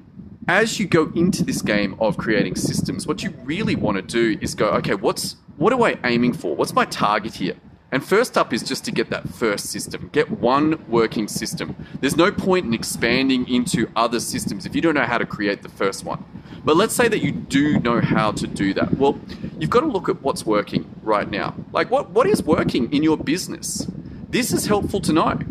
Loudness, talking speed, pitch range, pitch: -21 LUFS, 220 wpm, 120-175 Hz, 135 Hz